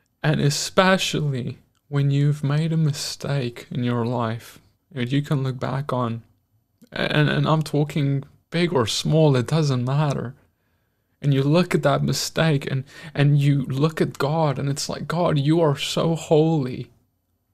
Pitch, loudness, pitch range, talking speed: 145 Hz, -22 LUFS, 125-155 Hz, 155 wpm